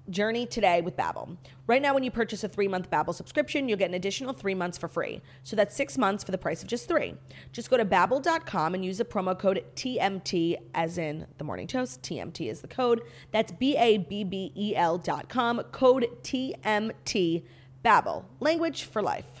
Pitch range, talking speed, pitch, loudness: 180-245 Hz, 200 wpm, 210 Hz, -28 LUFS